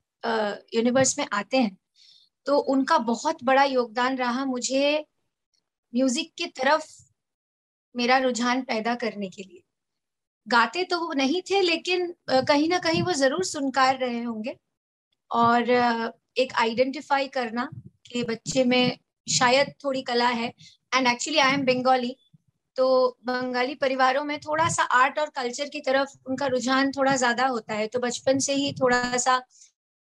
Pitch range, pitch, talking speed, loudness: 245-280 Hz, 260 Hz, 150 wpm, -24 LUFS